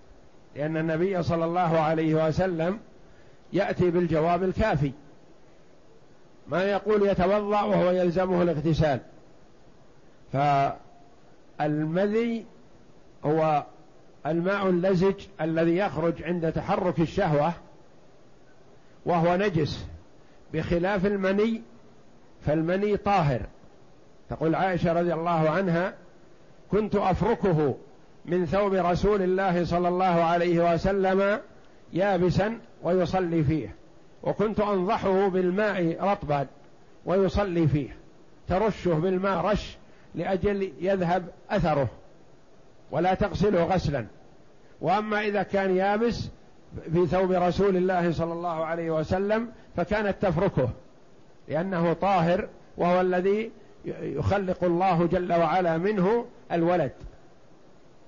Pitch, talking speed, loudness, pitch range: 180 Hz, 90 wpm, -26 LUFS, 165-195 Hz